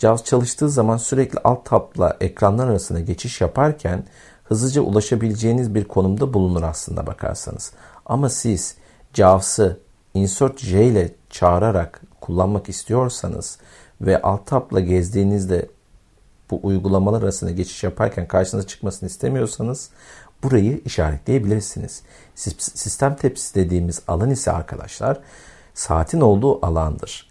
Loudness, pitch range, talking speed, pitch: -20 LUFS, 90-120 Hz, 110 wpm, 100 Hz